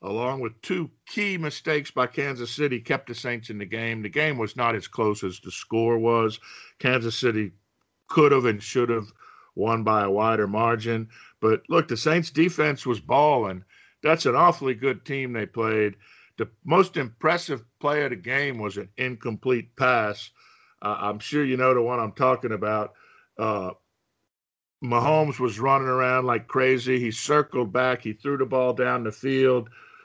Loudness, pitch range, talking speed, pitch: -24 LUFS, 110-135 Hz, 175 wpm, 120 Hz